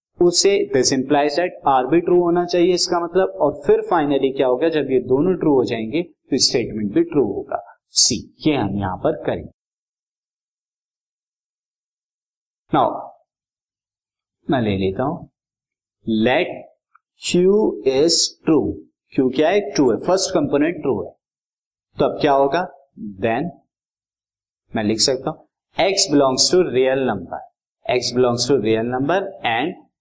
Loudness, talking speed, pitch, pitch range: -18 LUFS, 140 wpm, 140 Hz, 125-180 Hz